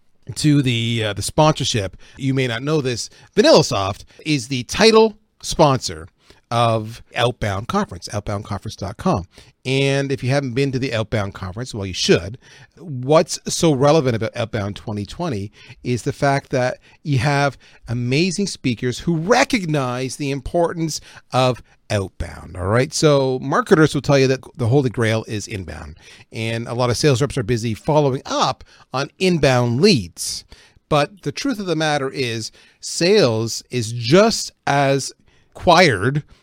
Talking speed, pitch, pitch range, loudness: 150 wpm, 130 Hz, 110-145 Hz, -19 LUFS